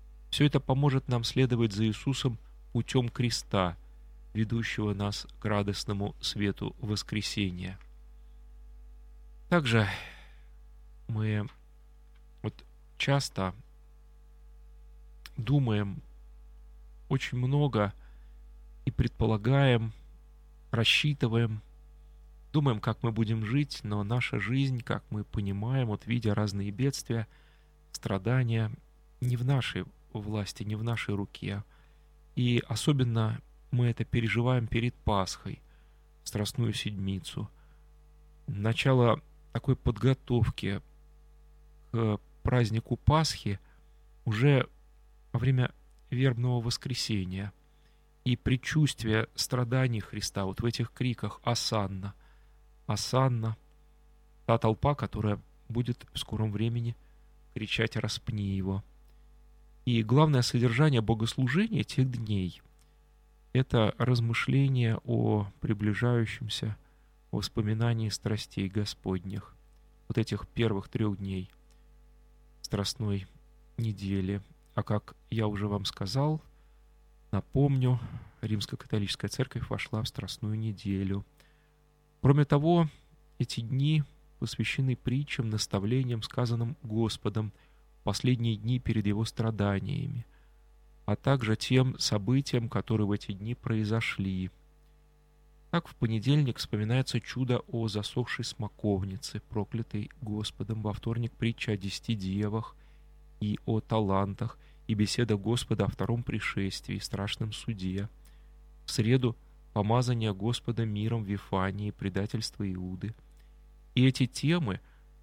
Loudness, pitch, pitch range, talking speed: -31 LUFS, 110 Hz, 95-125 Hz, 95 wpm